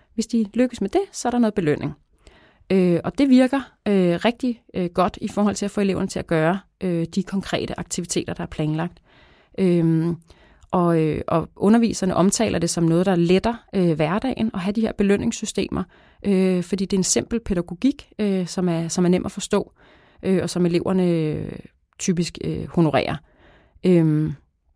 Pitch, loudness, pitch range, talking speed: 185 Hz, -22 LUFS, 170-210 Hz, 145 wpm